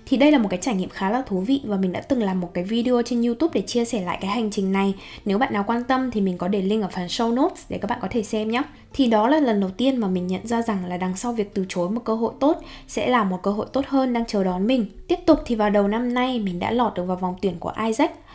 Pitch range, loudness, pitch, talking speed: 195-250 Hz, -23 LUFS, 220 Hz, 320 wpm